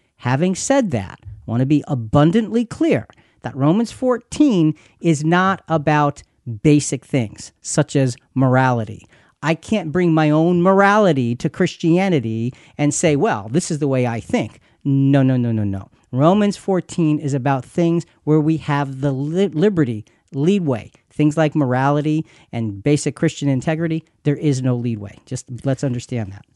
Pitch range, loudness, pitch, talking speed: 125-165 Hz, -18 LUFS, 145 Hz, 155 wpm